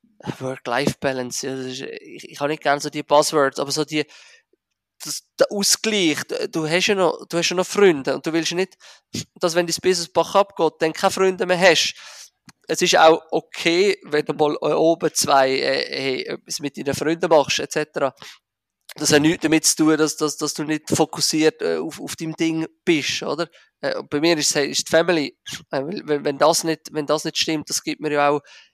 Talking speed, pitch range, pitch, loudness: 195 wpm, 150-175 Hz, 160 Hz, -20 LUFS